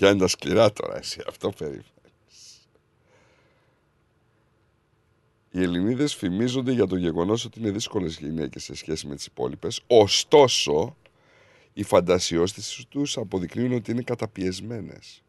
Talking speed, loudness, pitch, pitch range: 120 wpm, -24 LUFS, 105 Hz, 90-120 Hz